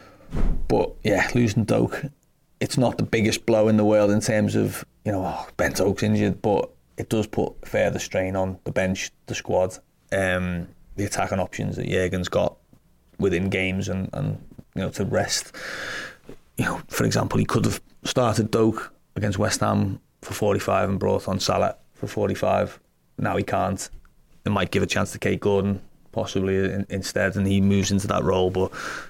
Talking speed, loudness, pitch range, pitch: 180 wpm, -24 LUFS, 95-105 Hz, 100 Hz